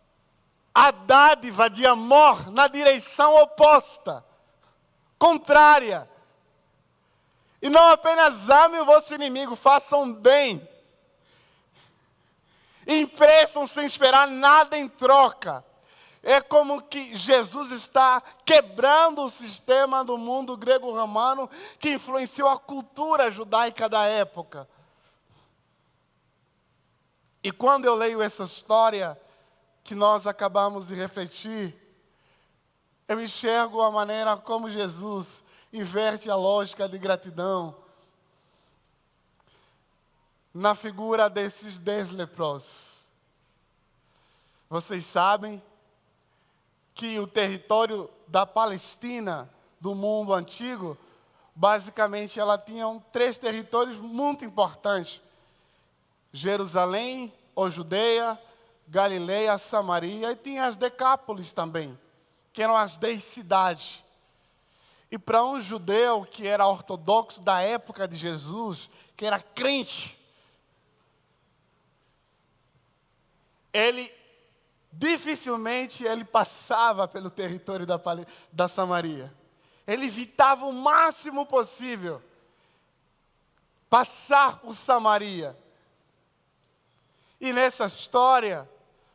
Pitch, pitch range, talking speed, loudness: 220 Hz, 195-260 Hz, 90 wpm, -22 LUFS